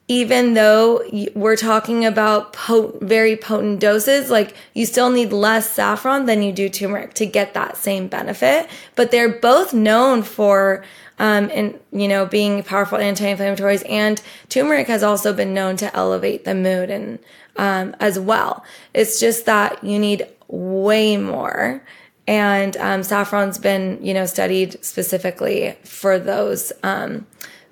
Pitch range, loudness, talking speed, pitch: 195-225 Hz, -17 LUFS, 150 wpm, 210 Hz